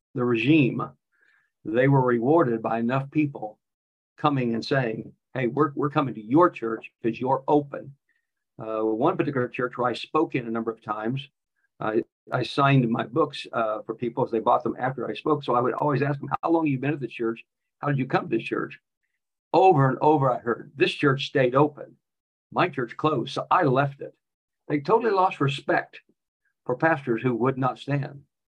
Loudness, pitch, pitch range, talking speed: -25 LUFS, 135 Hz, 115-150 Hz, 200 wpm